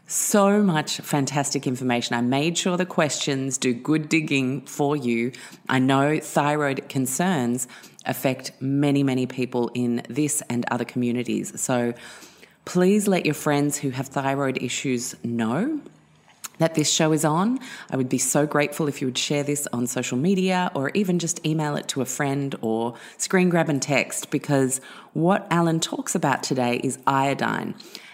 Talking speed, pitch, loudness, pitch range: 160 wpm, 140 Hz, -23 LUFS, 125-160 Hz